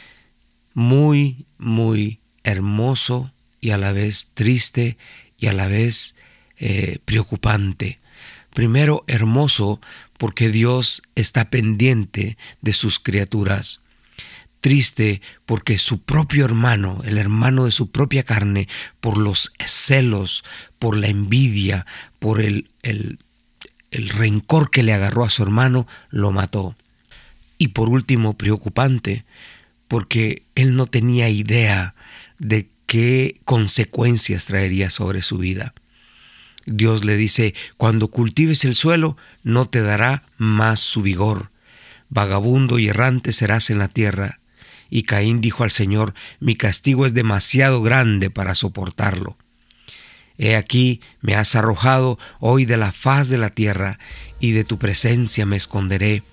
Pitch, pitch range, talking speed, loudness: 110 Hz, 105-125 Hz, 125 wpm, -17 LUFS